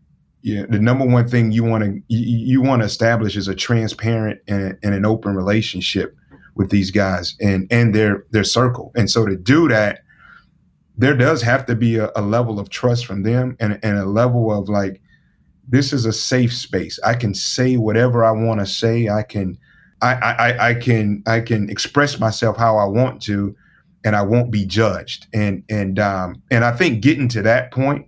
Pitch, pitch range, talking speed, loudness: 110 Hz, 100-120 Hz, 200 wpm, -18 LUFS